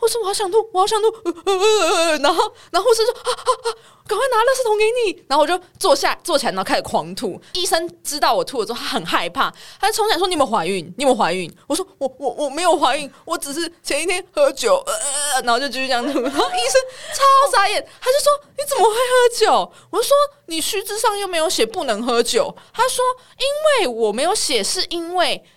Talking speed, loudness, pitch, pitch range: 340 characters per minute, -18 LUFS, 345 Hz, 280-430 Hz